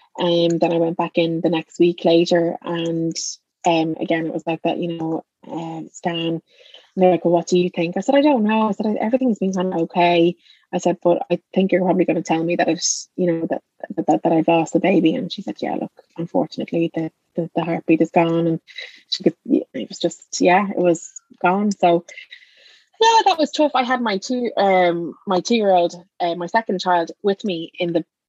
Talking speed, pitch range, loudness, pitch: 220 wpm, 165-190 Hz, -19 LUFS, 175 Hz